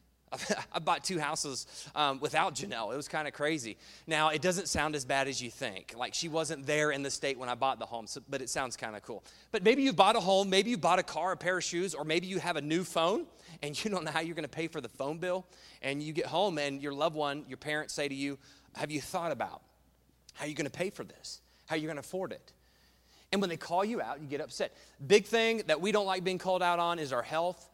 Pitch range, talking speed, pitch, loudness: 135-180 Hz, 275 wpm, 155 Hz, -32 LUFS